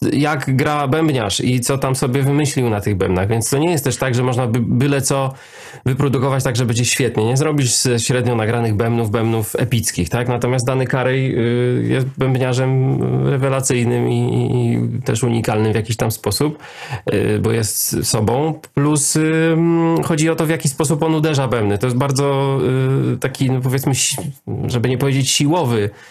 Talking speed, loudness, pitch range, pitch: 170 wpm, -17 LUFS, 115-140 Hz, 130 Hz